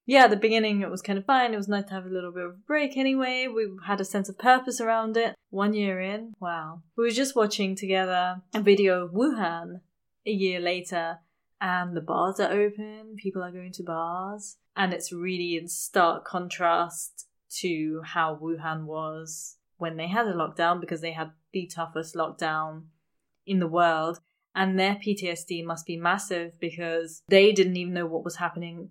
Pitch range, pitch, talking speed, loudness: 170-205 Hz, 180 Hz, 195 wpm, -27 LUFS